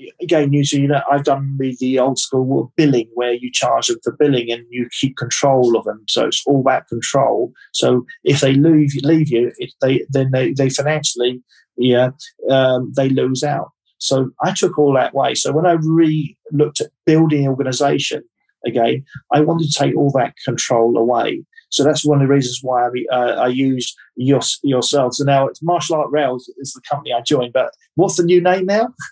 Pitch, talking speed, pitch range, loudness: 140 Hz, 200 wpm, 125-150 Hz, -16 LUFS